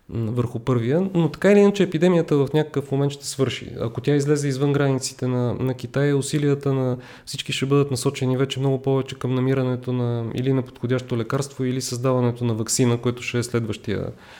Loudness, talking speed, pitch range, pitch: -22 LUFS, 185 wpm, 125-140 Hz, 130 Hz